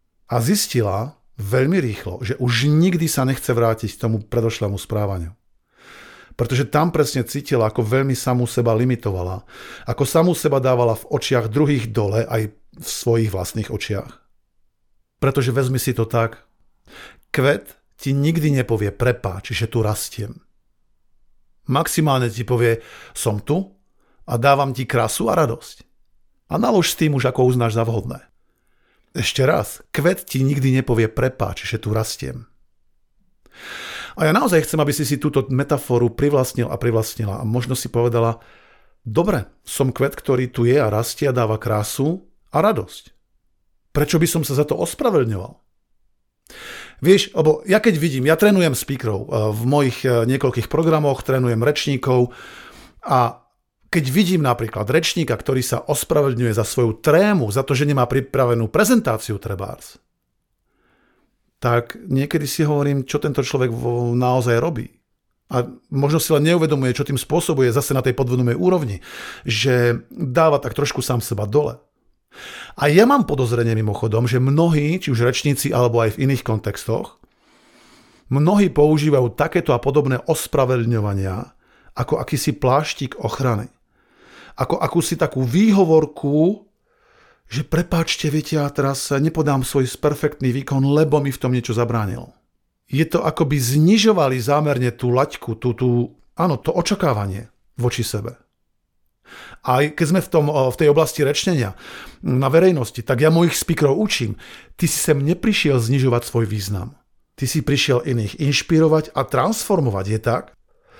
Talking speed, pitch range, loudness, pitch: 145 wpm, 120-150 Hz, -19 LUFS, 130 Hz